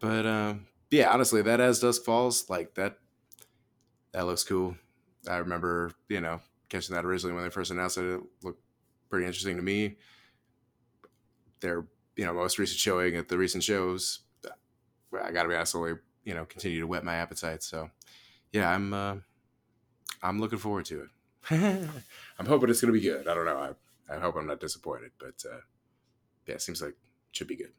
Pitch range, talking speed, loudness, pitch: 90-115 Hz, 190 wpm, -30 LUFS, 95 Hz